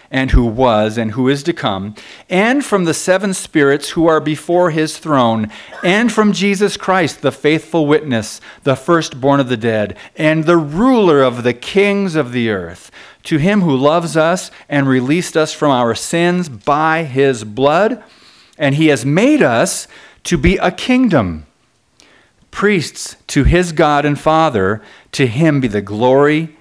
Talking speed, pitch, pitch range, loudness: 165 wpm, 155 Hz, 130-175 Hz, -14 LUFS